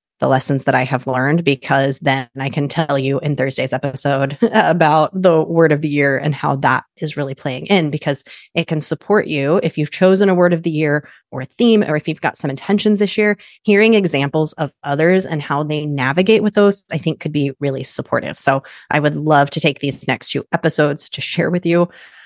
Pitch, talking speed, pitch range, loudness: 150 Hz, 220 wpm, 140-175 Hz, -16 LUFS